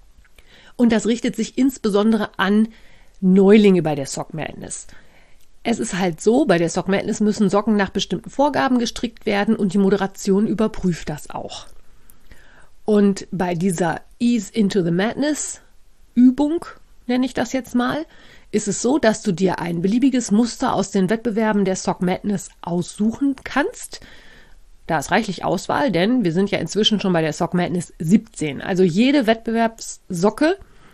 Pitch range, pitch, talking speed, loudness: 185-230 Hz, 210 Hz, 155 wpm, -19 LUFS